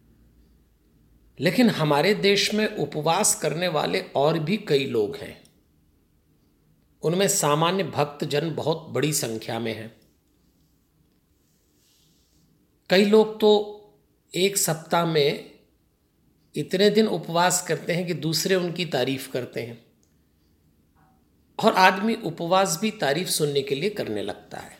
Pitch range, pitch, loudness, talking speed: 125-195 Hz, 160 Hz, -23 LUFS, 115 wpm